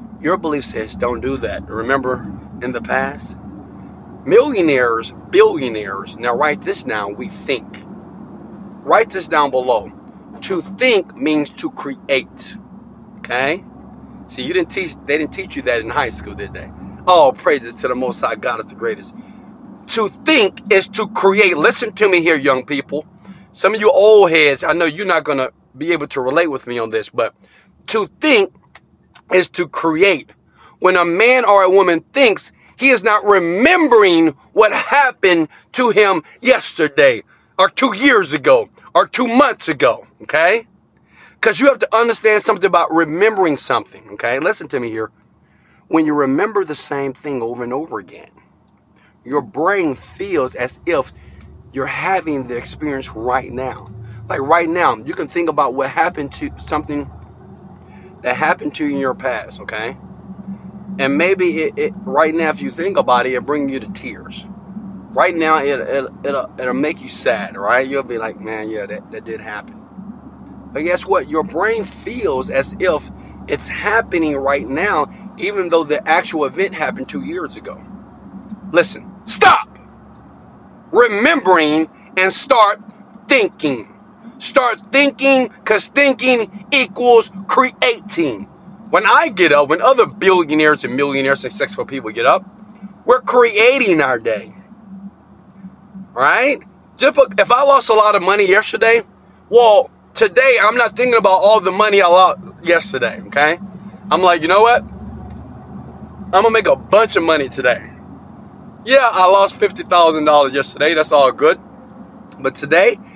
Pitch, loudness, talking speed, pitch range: 195 Hz, -15 LUFS, 160 wpm, 150-230 Hz